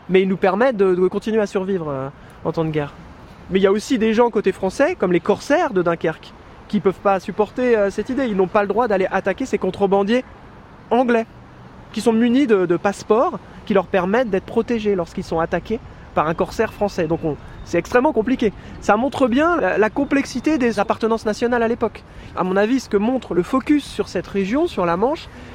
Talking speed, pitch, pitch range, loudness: 220 wpm, 205 Hz, 190-235 Hz, -19 LUFS